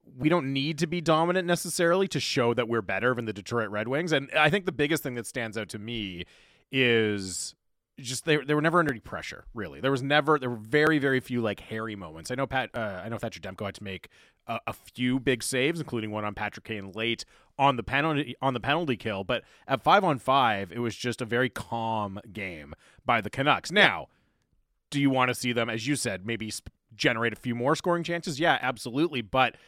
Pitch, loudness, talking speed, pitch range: 120 Hz, -27 LUFS, 230 wpm, 110-145 Hz